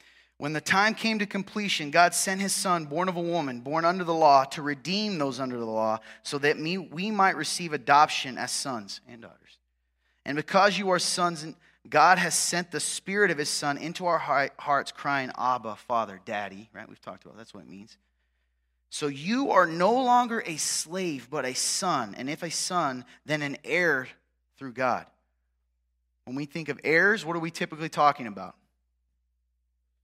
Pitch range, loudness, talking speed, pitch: 105-175 Hz, -26 LUFS, 185 wpm, 150 Hz